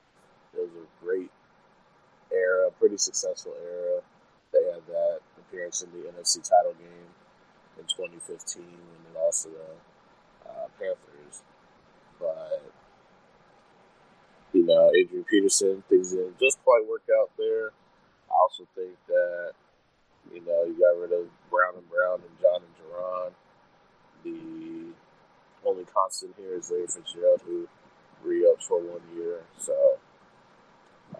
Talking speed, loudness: 125 wpm, -26 LUFS